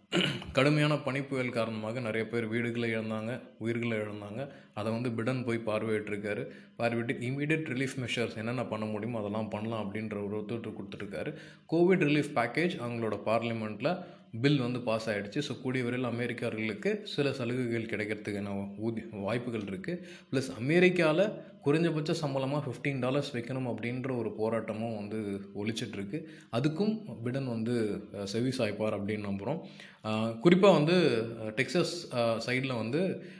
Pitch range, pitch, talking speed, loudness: 110-140 Hz, 120 Hz, 125 wpm, -32 LUFS